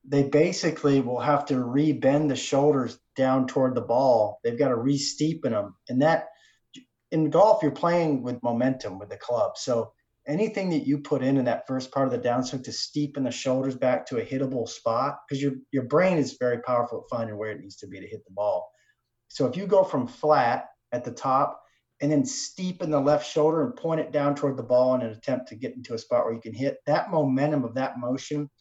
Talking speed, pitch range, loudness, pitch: 225 wpm, 130-150 Hz, -25 LUFS, 140 Hz